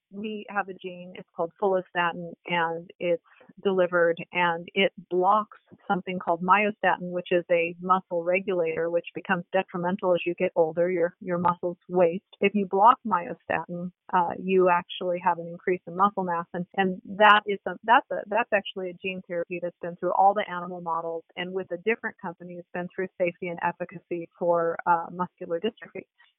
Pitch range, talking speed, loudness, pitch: 175-190 Hz, 180 wpm, -26 LUFS, 180 Hz